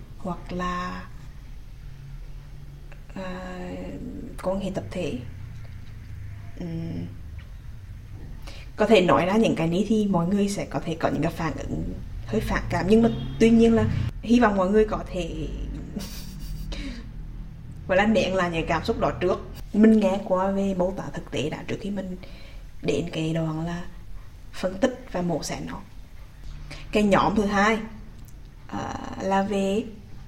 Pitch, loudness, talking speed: 160 Hz, -25 LUFS, 155 wpm